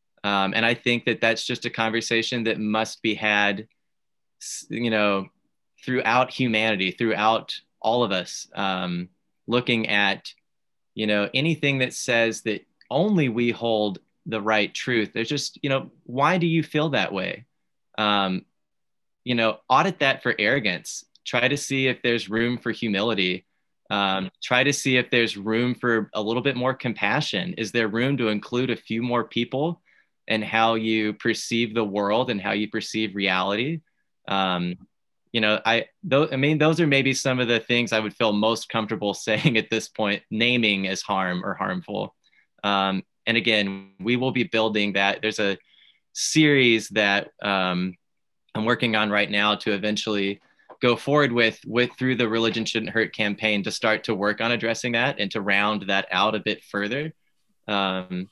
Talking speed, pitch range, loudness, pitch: 175 wpm, 100-120 Hz, -23 LUFS, 110 Hz